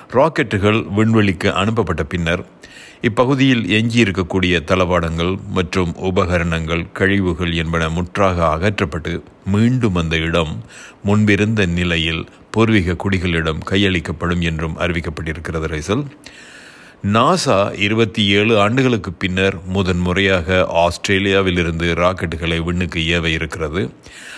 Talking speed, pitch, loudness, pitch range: 85 wpm, 95 Hz, -17 LUFS, 85-100 Hz